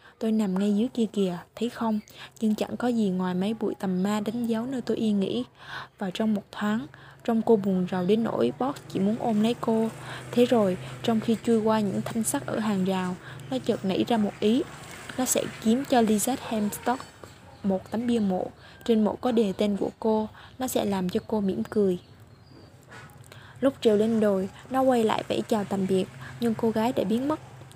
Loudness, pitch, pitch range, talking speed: -27 LUFS, 220 Hz, 195-230 Hz, 210 wpm